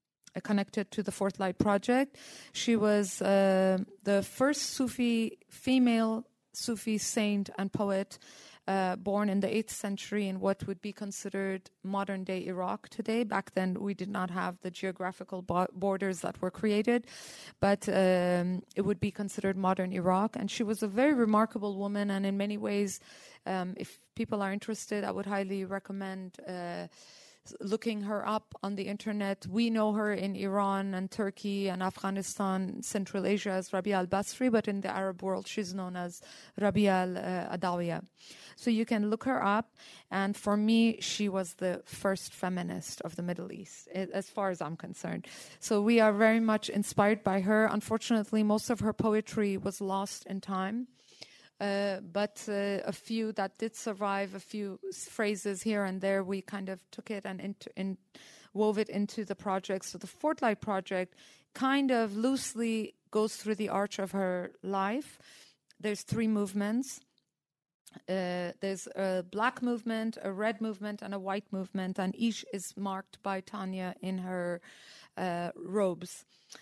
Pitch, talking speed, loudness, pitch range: 200 Hz, 165 wpm, -32 LUFS, 190-215 Hz